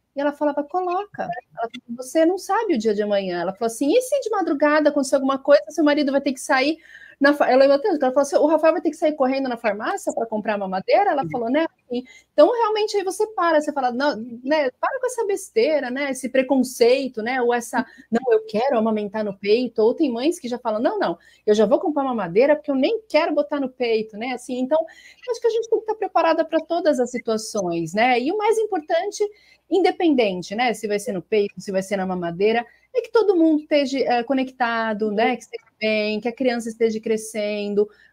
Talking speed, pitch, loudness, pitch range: 230 wpm, 270 Hz, -21 LUFS, 230-325 Hz